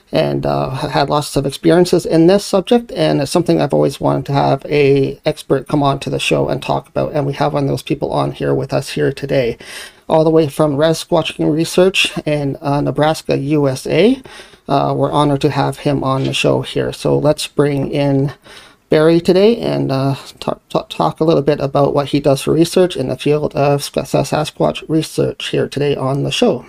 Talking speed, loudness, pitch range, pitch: 205 wpm, -15 LUFS, 140-160 Hz, 145 Hz